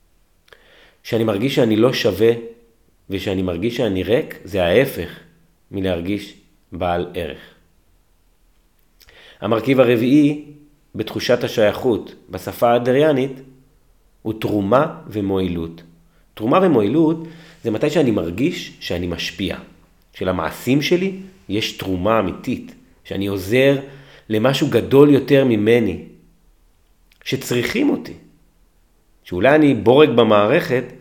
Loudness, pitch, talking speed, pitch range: -18 LUFS, 110 Hz, 95 wpm, 95-135 Hz